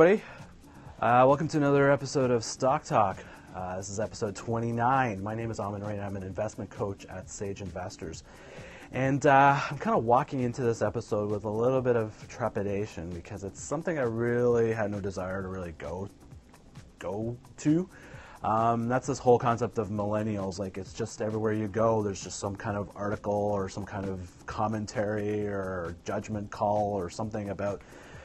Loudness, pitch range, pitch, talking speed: -29 LUFS, 100-120 Hz, 105 Hz, 180 wpm